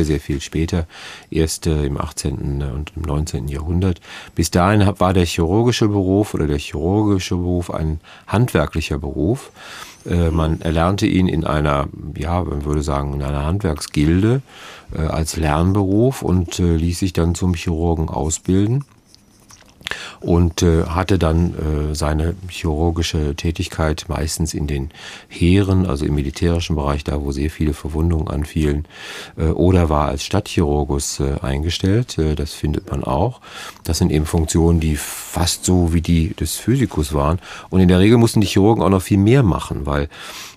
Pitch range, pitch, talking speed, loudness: 75-95 Hz, 85 Hz, 150 wpm, -19 LUFS